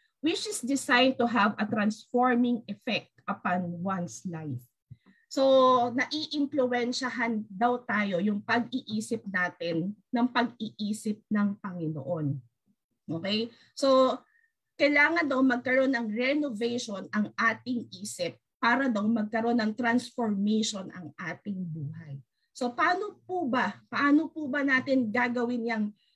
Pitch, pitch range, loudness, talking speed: 235 Hz, 205-255 Hz, -28 LUFS, 115 wpm